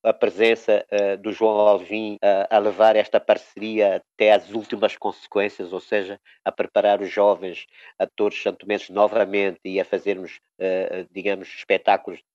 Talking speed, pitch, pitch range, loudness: 150 wpm, 100 Hz, 100-105 Hz, -21 LUFS